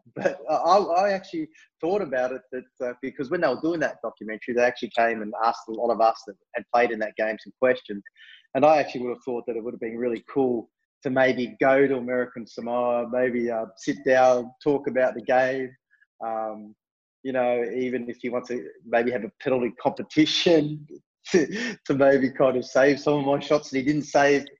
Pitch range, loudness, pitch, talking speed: 120-140 Hz, -24 LUFS, 125 Hz, 205 wpm